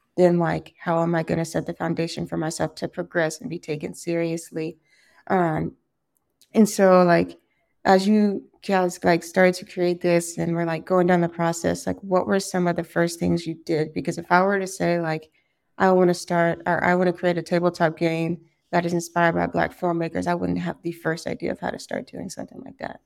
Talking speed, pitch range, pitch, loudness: 225 wpm, 165-180 Hz, 170 Hz, -23 LUFS